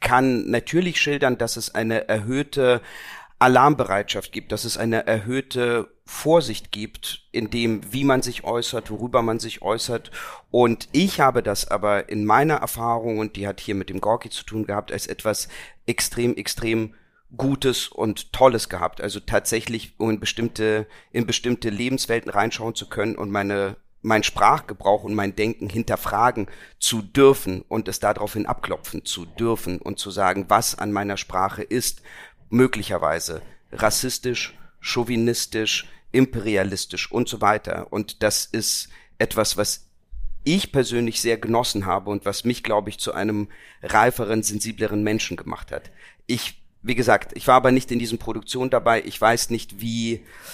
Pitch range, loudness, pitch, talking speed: 105-120 Hz, -22 LUFS, 110 Hz, 155 wpm